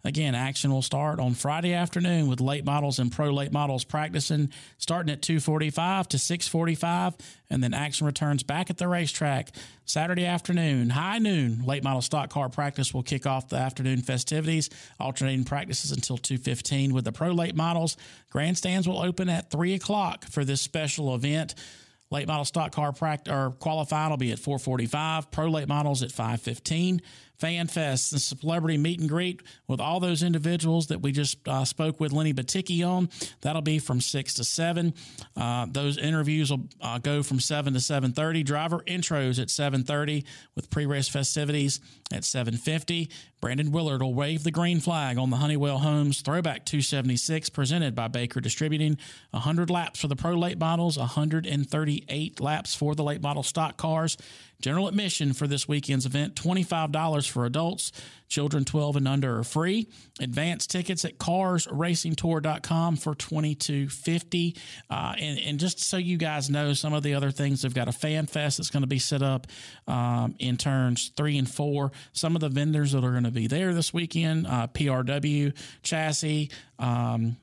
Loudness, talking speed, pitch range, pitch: -27 LUFS, 180 wpm, 135-160 Hz, 150 Hz